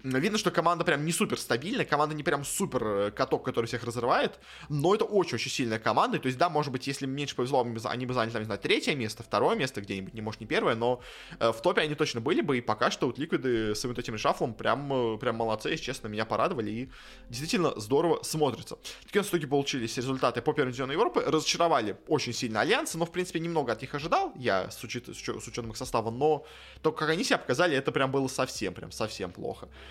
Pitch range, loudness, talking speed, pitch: 115-155 Hz, -29 LUFS, 220 wpm, 130 Hz